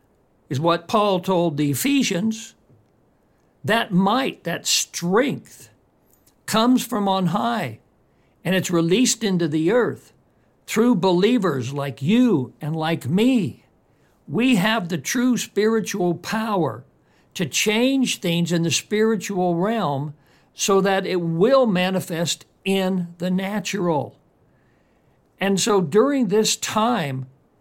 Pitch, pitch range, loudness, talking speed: 190 Hz, 165-220 Hz, -21 LUFS, 115 wpm